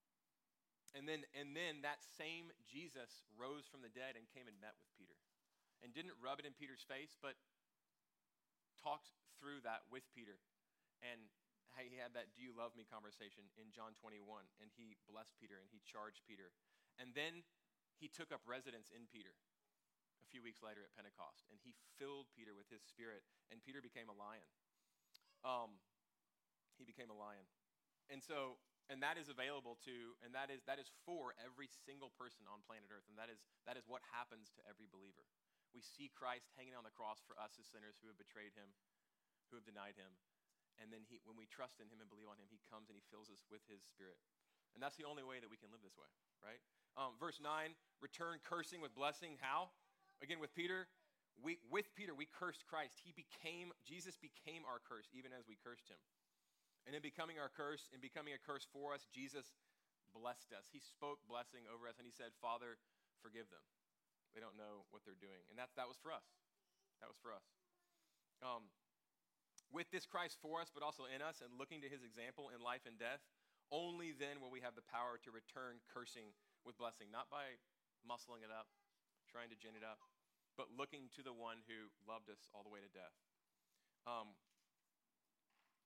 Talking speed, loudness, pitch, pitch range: 200 wpm, -54 LUFS, 120 Hz, 110-145 Hz